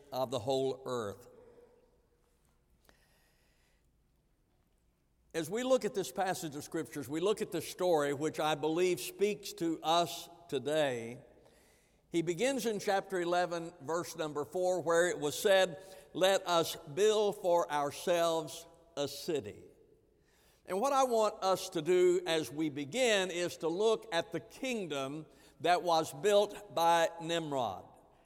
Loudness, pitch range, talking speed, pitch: -33 LUFS, 160-195 Hz, 135 wpm, 170 Hz